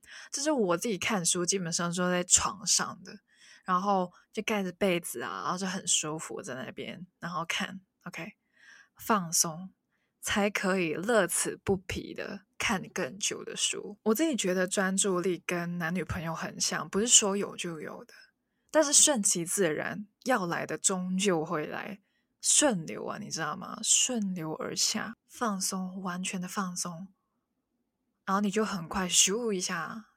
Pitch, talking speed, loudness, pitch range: 195 Hz, 225 characters per minute, -29 LUFS, 180-220 Hz